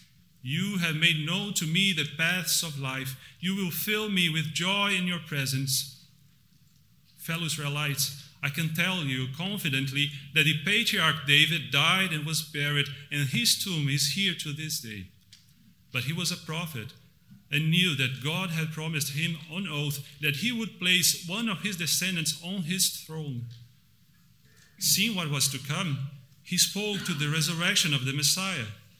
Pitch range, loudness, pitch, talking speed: 145-175 Hz, -27 LUFS, 155 Hz, 165 wpm